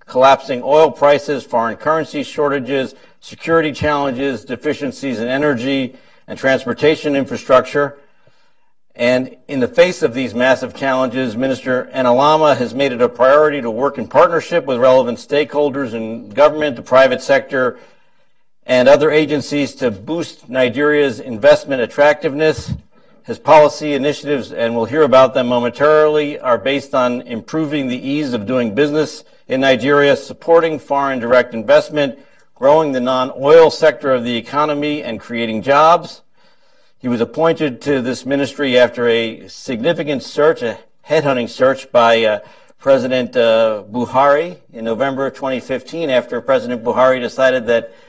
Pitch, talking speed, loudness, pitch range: 135 Hz, 135 wpm, -15 LUFS, 125-150 Hz